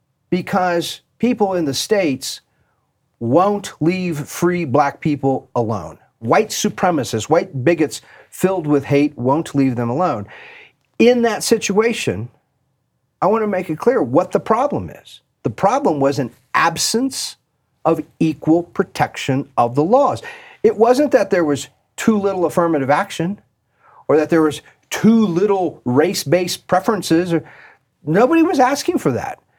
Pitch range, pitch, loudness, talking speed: 145-210 Hz, 170 Hz, -17 LUFS, 140 wpm